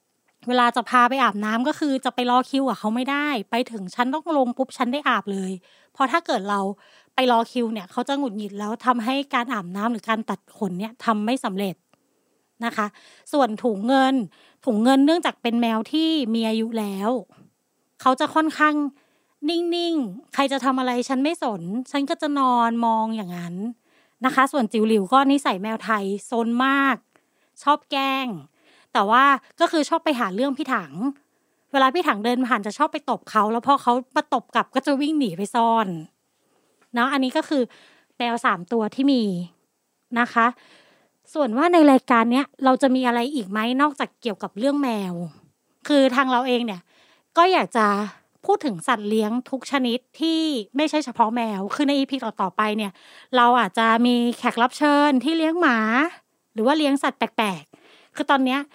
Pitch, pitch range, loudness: 250 Hz, 225-280 Hz, -22 LUFS